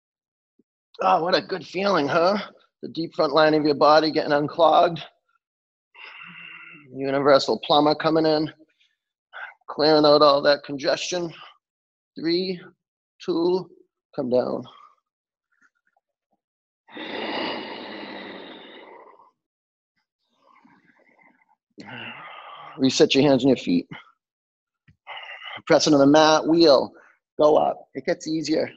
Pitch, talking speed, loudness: 170 Hz, 90 wpm, -20 LUFS